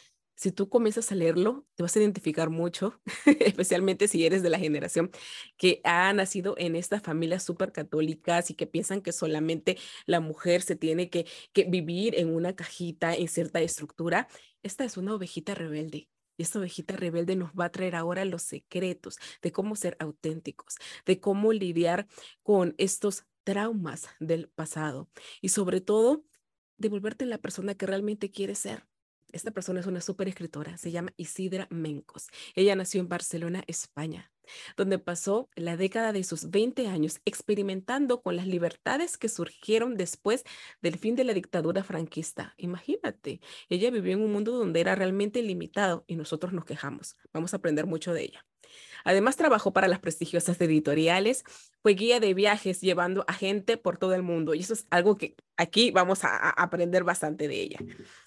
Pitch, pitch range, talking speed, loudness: 185 Hz, 170-200 Hz, 170 wpm, -29 LUFS